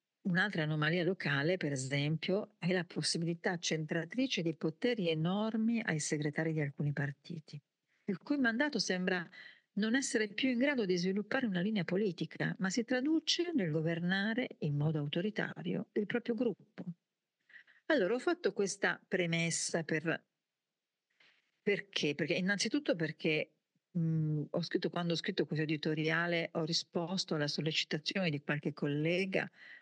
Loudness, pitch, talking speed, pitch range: -35 LUFS, 175 Hz, 135 wpm, 160-210 Hz